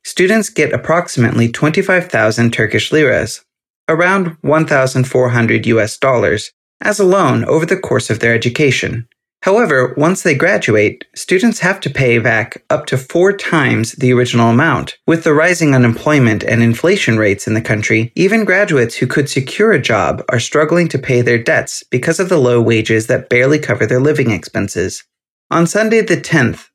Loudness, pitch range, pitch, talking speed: -13 LUFS, 115-165 Hz, 130 Hz, 165 wpm